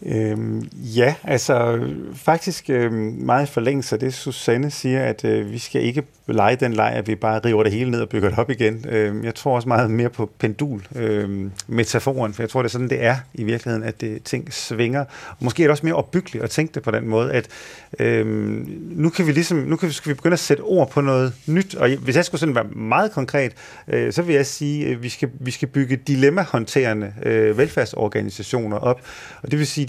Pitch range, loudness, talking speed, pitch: 110-145 Hz, -21 LUFS, 225 wpm, 125 Hz